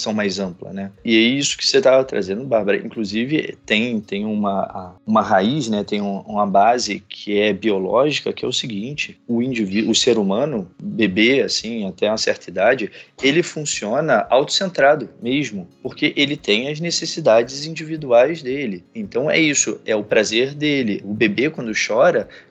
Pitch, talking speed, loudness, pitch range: 125 Hz, 165 wpm, -19 LUFS, 105-155 Hz